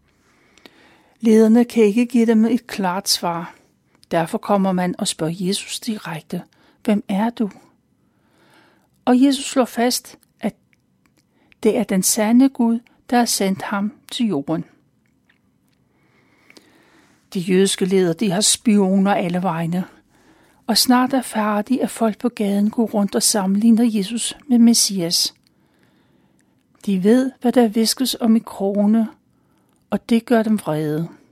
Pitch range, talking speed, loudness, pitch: 195-235 Hz, 135 wpm, -18 LUFS, 220 Hz